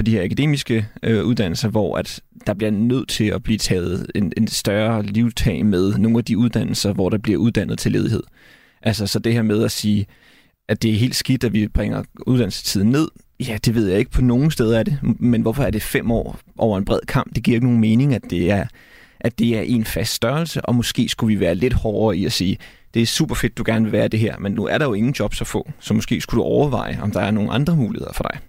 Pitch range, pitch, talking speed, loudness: 105-120 Hz, 115 Hz, 255 wpm, -19 LUFS